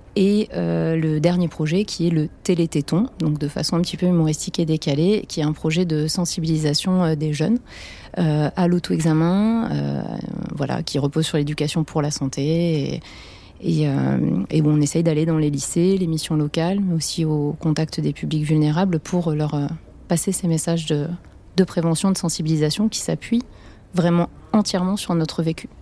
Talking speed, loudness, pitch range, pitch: 180 wpm, -21 LUFS, 155-180 Hz, 165 Hz